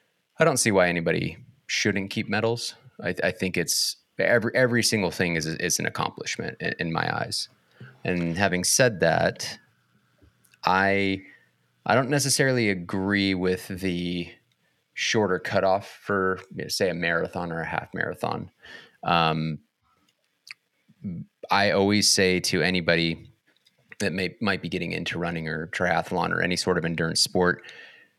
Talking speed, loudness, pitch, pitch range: 150 wpm, -25 LUFS, 95 Hz, 85-105 Hz